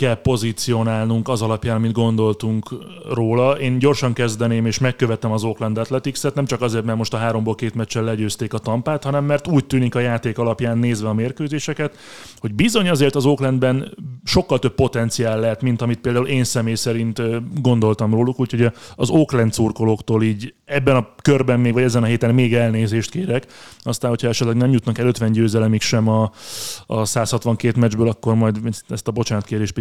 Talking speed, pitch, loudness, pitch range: 175 wpm, 120 Hz, -19 LUFS, 115-130 Hz